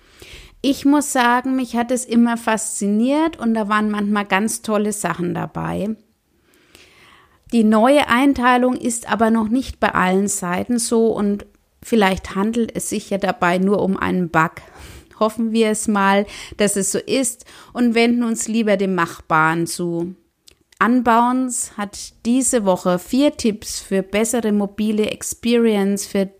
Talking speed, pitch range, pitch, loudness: 145 wpm, 195-240 Hz, 220 Hz, -18 LUFS